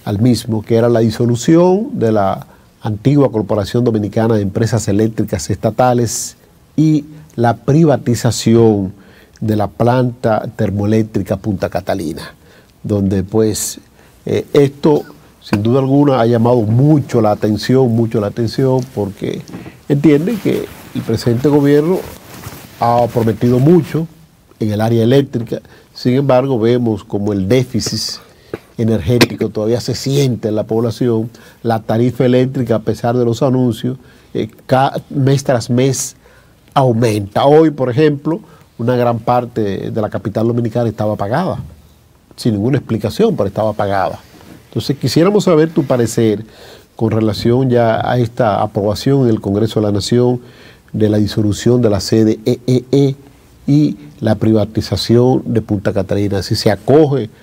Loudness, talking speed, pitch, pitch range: -14 LUFS, 135 wpm, 115 Hz, 110-130 Hz